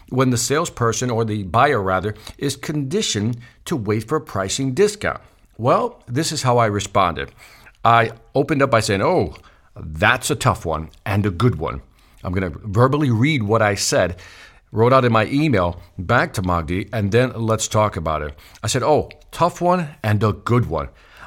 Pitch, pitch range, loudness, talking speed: 115 Hz, 100-130 Hz, -19 LUFS, 185 wpm